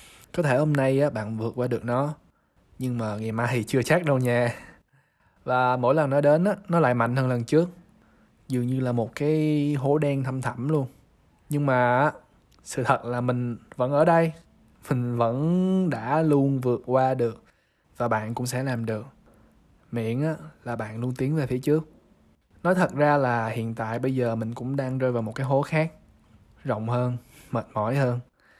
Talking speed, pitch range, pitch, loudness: 195 wpm, 120-145 Hz, 125 Hz, -25 LUFS